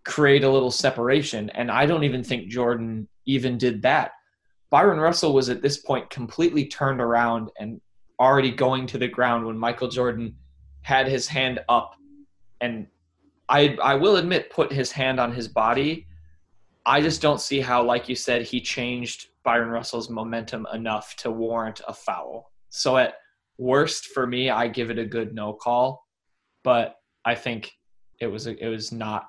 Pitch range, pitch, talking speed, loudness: 115-135 Hz, 125 Hz, 175 wpm, -23 LUFS